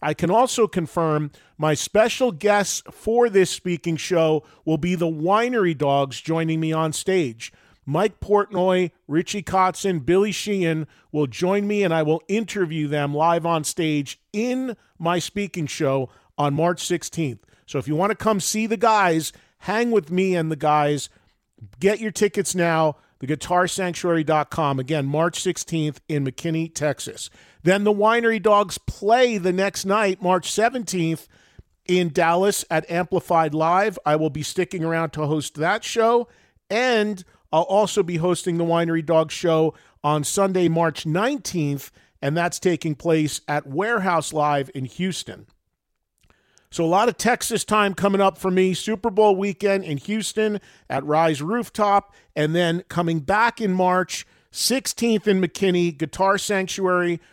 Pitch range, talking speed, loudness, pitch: 155-200 Hz, 150 wpm, -22 LUFS, 175 Hz